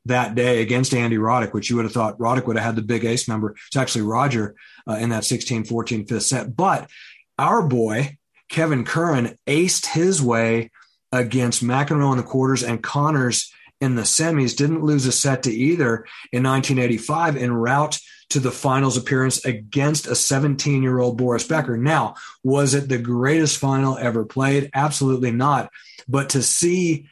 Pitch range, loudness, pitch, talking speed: 115-140 Hz, -20 LUFS, 130 Hz, 170 wpm